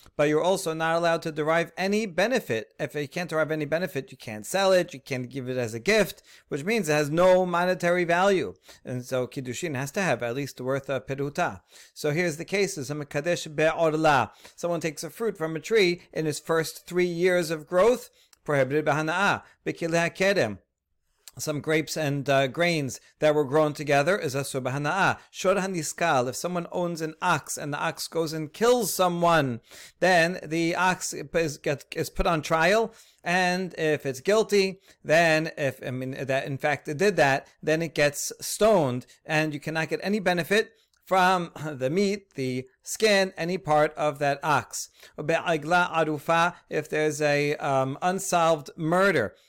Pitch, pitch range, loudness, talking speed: 160 Hz, 145-180 Hz, -25 LUFS, 165 wpm